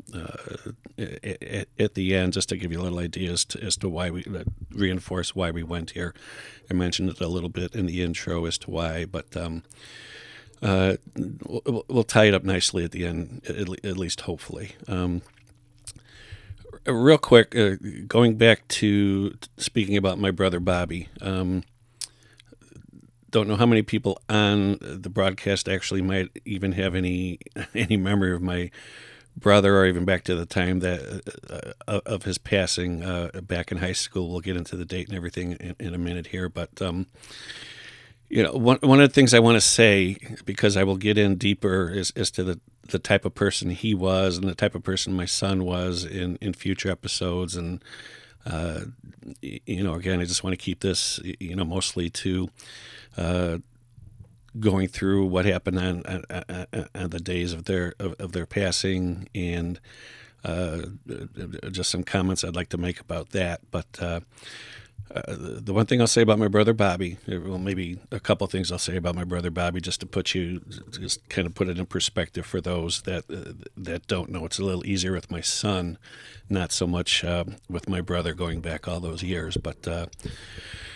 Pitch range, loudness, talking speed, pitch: 90-100 Hz, -25 LUFS, 190 wpm, 95 Hz